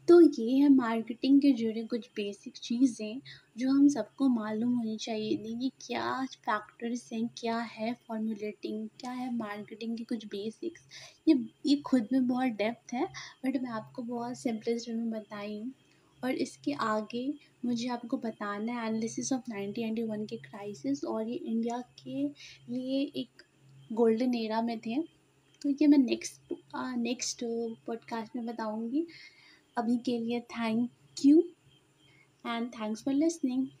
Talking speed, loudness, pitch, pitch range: 145 wpm, -32 LUFS, 235 Hz, 220-260 Hz